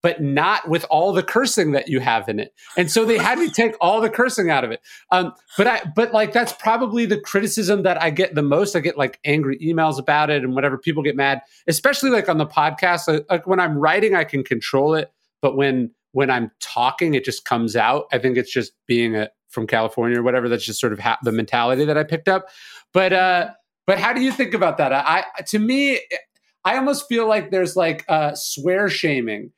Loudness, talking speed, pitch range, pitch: -19 LUFS, 235 wpm, 140-215 Hz, 170 Hz